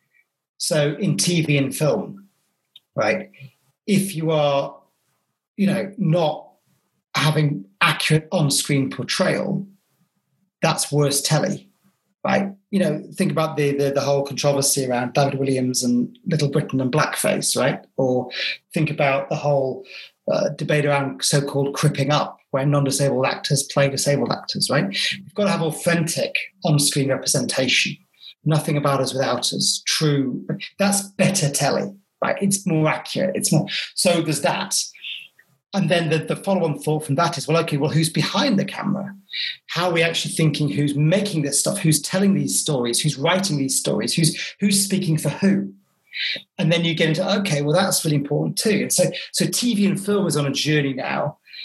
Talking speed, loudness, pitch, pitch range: 170 wpm, -20 LUFS, 160 Hz, 145-190 Hz